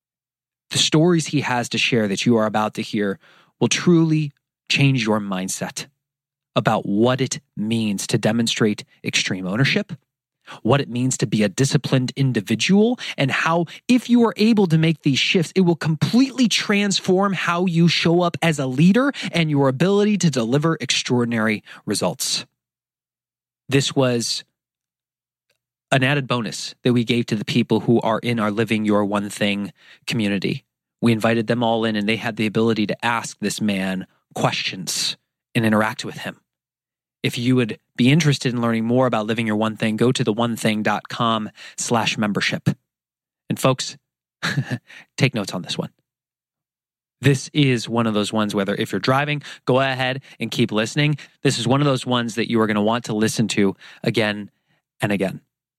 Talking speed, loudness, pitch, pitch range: 170 wpm, -20 LUFS, 125 Hz, 110-150 Hz